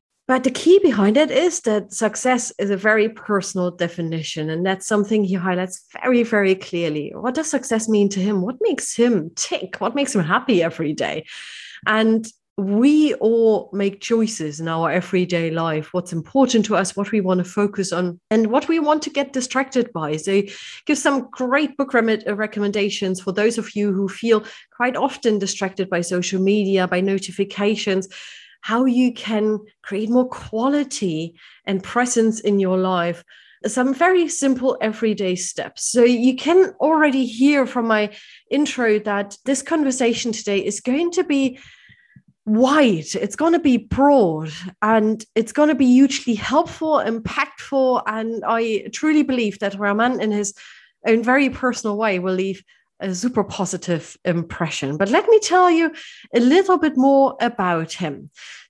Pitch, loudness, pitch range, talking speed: 220 Hz, -19 LUFS, 195-260 Hz, 165 wpm